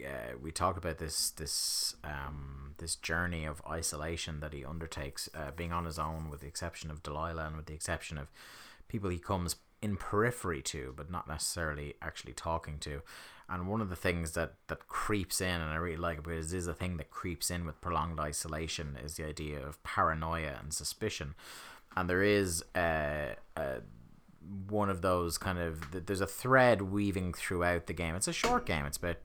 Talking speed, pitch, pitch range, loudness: 195 wpm, 85 Hz, 75-90 Hz, -35 LUFS